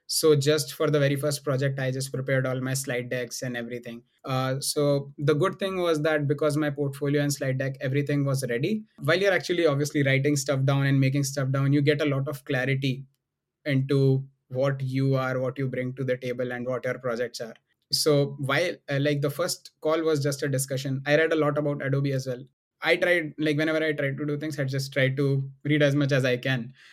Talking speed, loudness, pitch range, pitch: 225 wpm, -26 LUFS, 135-150 Hz, 140 Hz